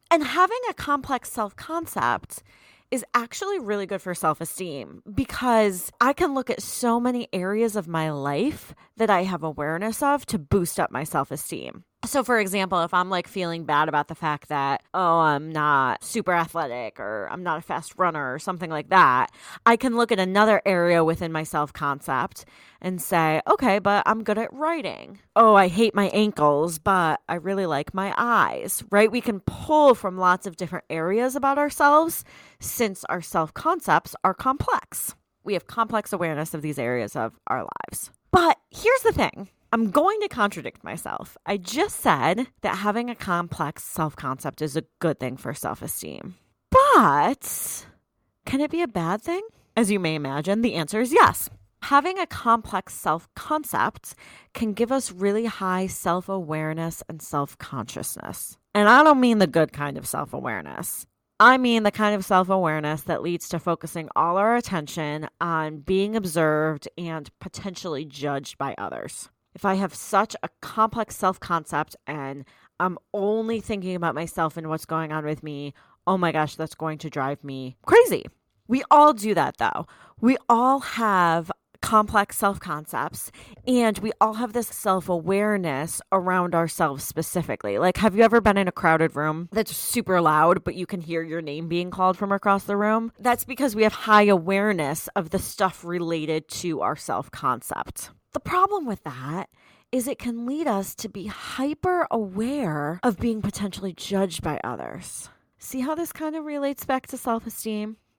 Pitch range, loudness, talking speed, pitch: 160-230 Hz, -23 LUFS, 180 wpm, 190 Hz